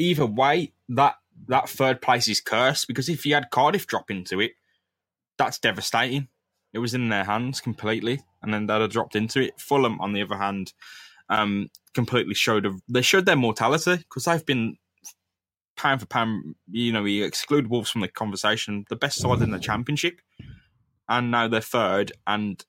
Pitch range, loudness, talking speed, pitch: 105-130 Hz, -24 LUFS, 185 wpm, 115 Hz